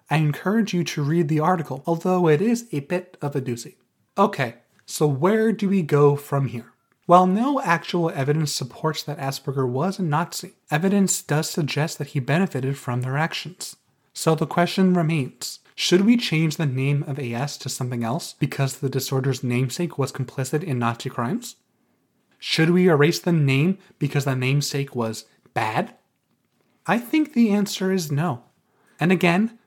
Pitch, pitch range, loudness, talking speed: 155 Hz, 135-180 Hz, -22 LUFS, 170 wpm